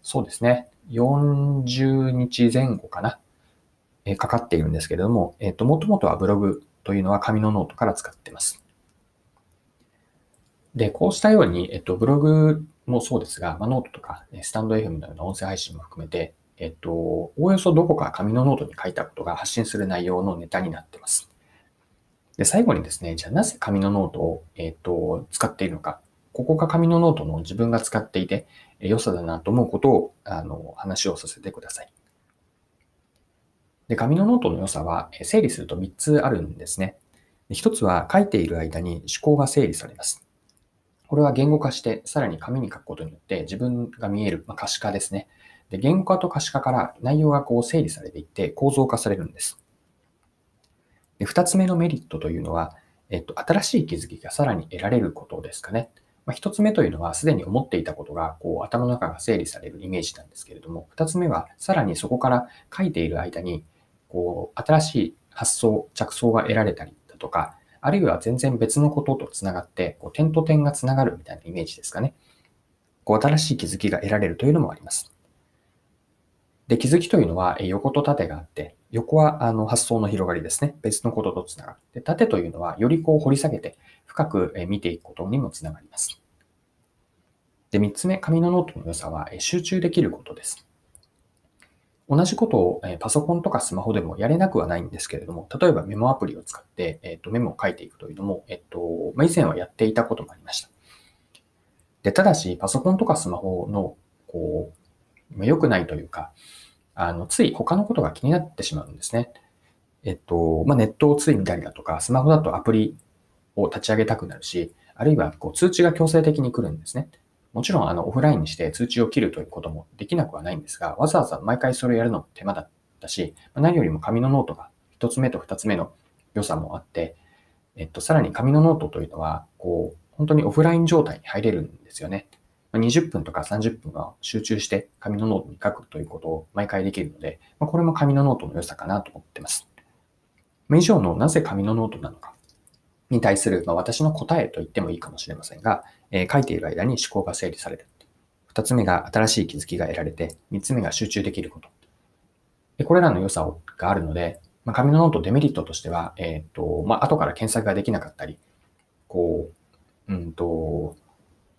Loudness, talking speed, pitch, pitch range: -23 LUFS, 380 characters per minute, 115 Hz, 90-145 Hz